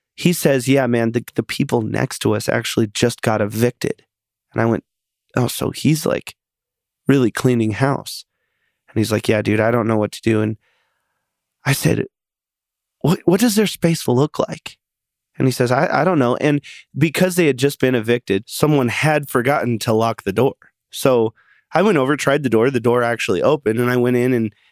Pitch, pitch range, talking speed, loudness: 125 Hz, 110-140 Hz, 200 wpm, -18 LUFS